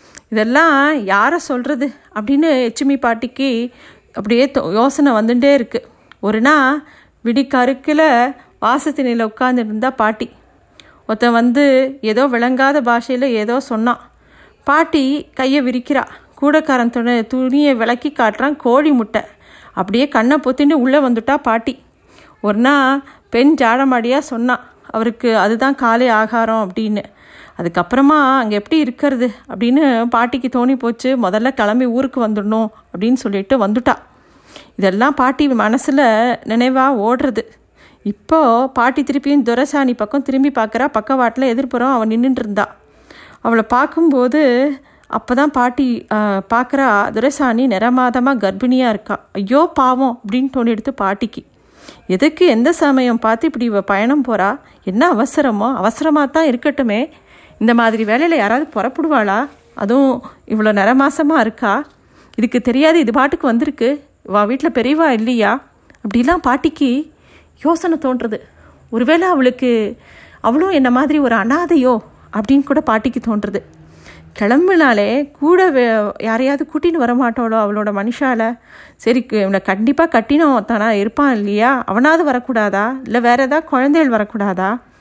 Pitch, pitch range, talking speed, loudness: 250 Hz, 225-280 Hz, 115 wpm, -15 LUFS